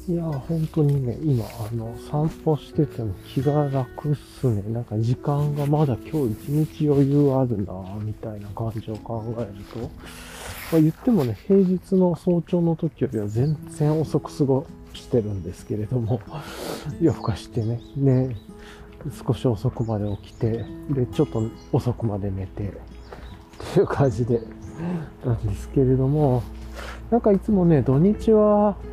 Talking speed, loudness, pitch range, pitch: 280 characters per minute, -23 LUFS, 110-155 Hz, 125 Hz